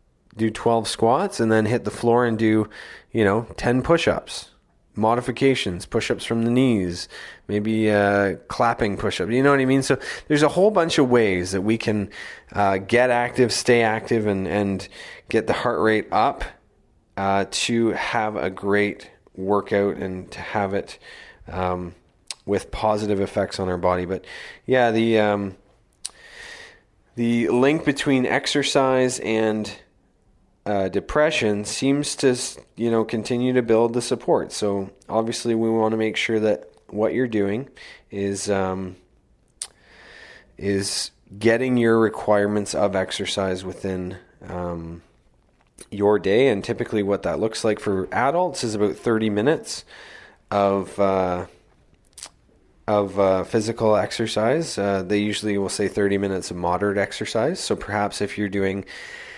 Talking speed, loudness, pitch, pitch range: 145 wpm, -22 LUFS, 105 Hz, 100-115 Hz